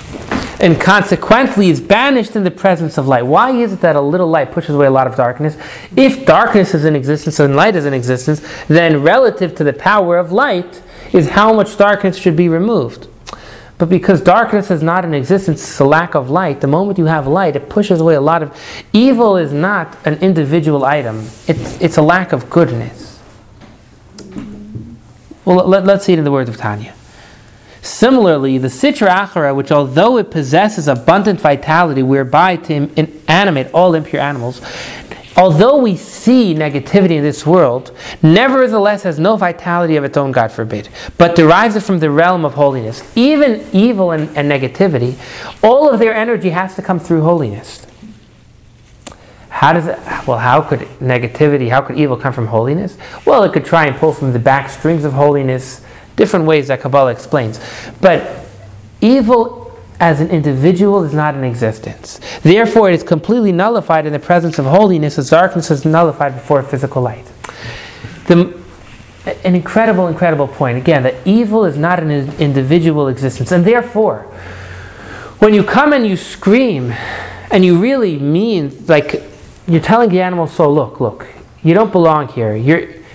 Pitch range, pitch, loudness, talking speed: 135-185 Hz, 160 Hz, -12 LUFS, 175 wpm